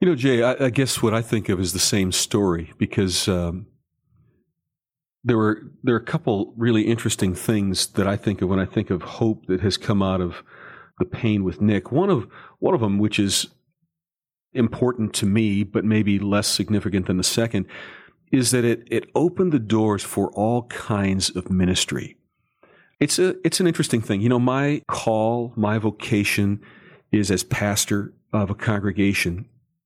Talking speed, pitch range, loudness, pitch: 180 wpm, 100-125 Hz, -22 LUFS, 110 Hz